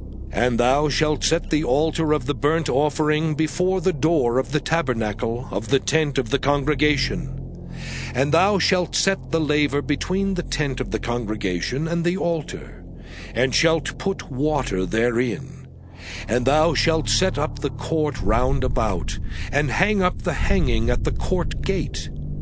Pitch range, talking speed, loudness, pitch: 120-160 Hz, 160 wpm, -22 LUFS, 145 Hz